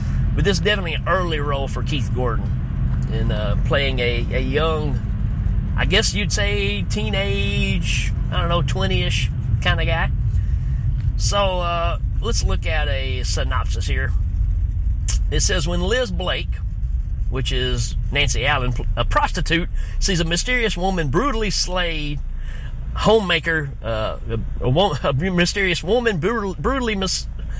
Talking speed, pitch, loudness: 135 wpm, 120 Hz, -21 LUFS